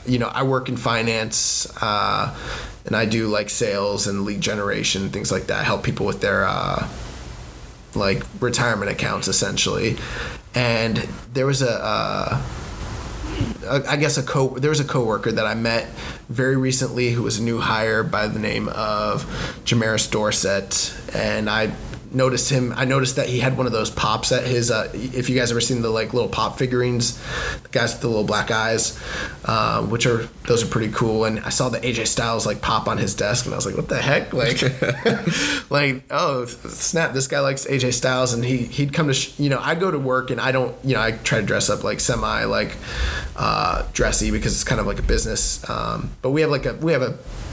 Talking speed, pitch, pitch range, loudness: 210 wpm, 120 Hz, 110-130 Hz, -20 LUFS